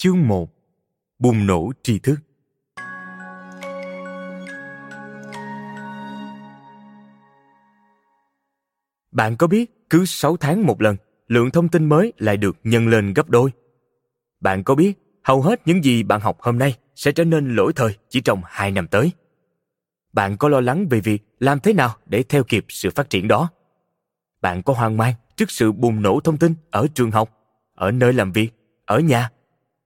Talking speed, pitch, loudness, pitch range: 160 wpm, 115 Hz, -19 LUFS, 100-140 Hz